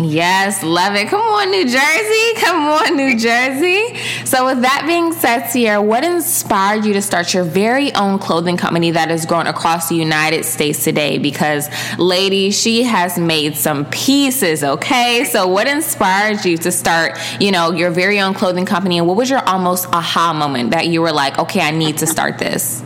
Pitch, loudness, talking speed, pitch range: 185 Hz, -14 LUFS, 190 wpm, 165-245 Hz